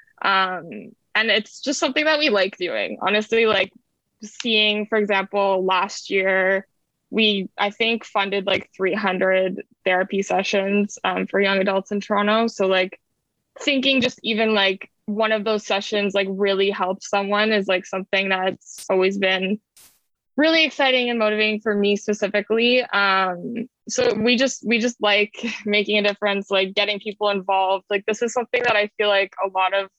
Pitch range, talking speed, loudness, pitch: 195-220 Hz, 165 wpm, -20 LUFS, 205 Hz